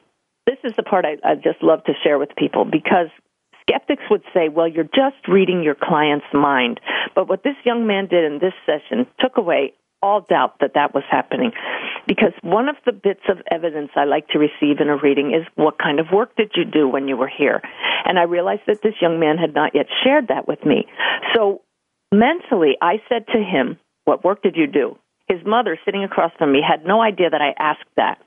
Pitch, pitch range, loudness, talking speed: 175 Hz, 150-220 Hz, -18 LUFS, 220 wpm